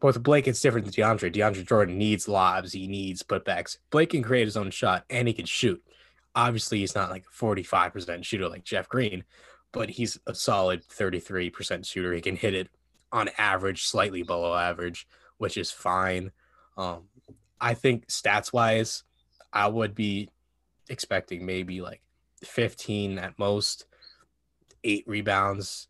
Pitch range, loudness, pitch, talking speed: 90-110 Hz, -27 LUFS, 100 Hz, 155 wpm